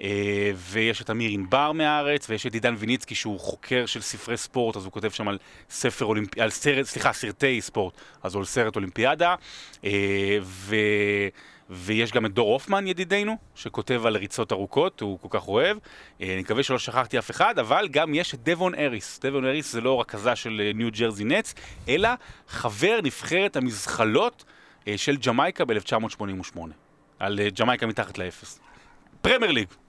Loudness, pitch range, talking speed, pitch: -25 LUFS, 100-130 Hz, 175 wpm, 110 Hz